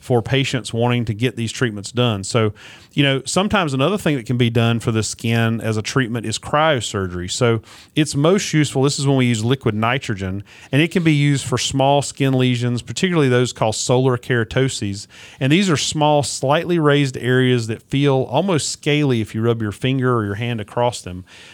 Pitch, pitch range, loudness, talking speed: 125 Hz, 115-140 Hz, -18 LUFS, 200 wpm